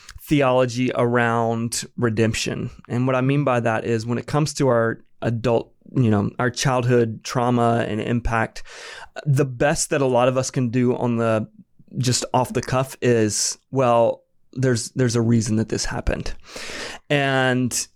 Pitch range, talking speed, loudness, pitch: 115-130 Hz, 160 wpm, -21 LUFS, 125 Hz